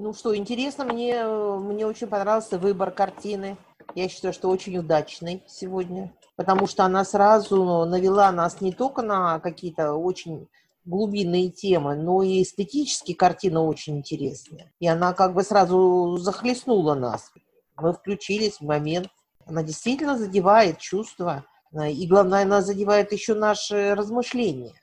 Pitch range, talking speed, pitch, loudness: 175-205 Hz, 135 wpm, 190 Hz, -23 LUFS